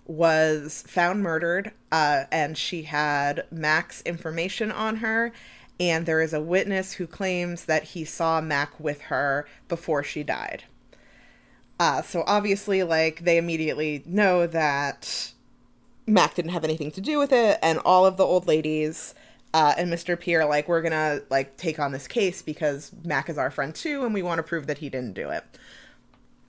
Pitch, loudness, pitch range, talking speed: 165 Hz, -25 LUFS, 155-180 Hz, 175 wpm